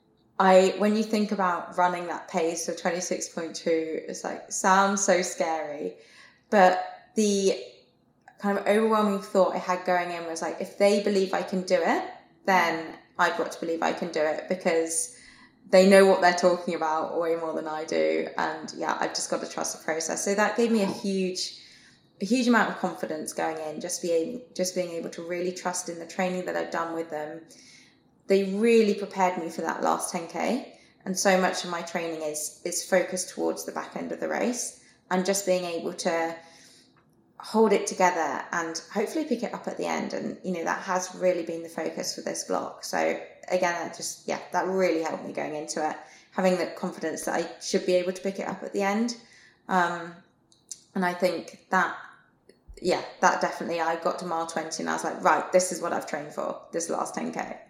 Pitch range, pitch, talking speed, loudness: 165-195 Hz, 180 Hz, 205 wpm, -27 LUFS